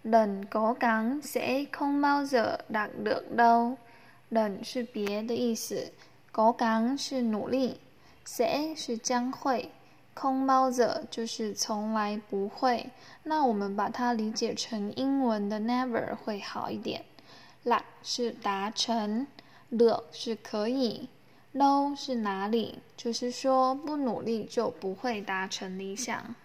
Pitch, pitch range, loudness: 235 Hz, 220-255 Hz, -30 LUFS